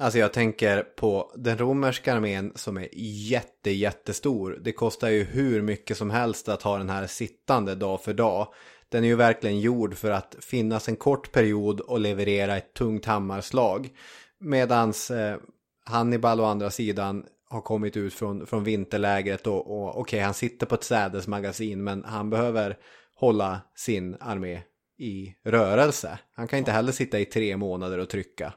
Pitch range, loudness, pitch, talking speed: 100-115 Hz, -26 LUFS, 105 Hz, 170 wpm